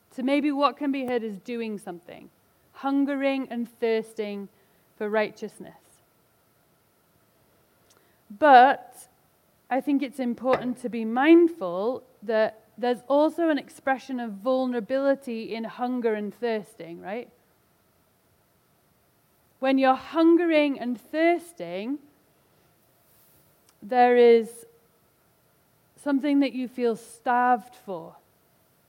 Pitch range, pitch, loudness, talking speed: 220-275 Hz, 245 Hz, -24 LUFS, 100 wpm